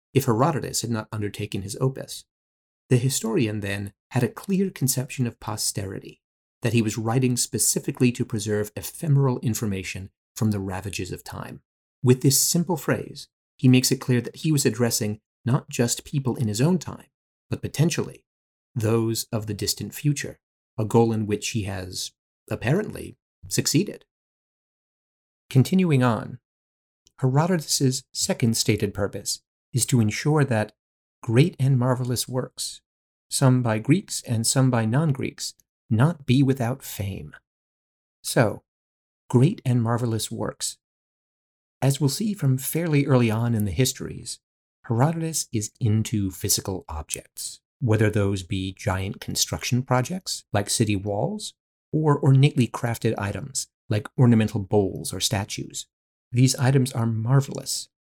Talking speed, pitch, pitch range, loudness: 135 wpm, 120 Hz, 105-135 Hz, -24 LUFS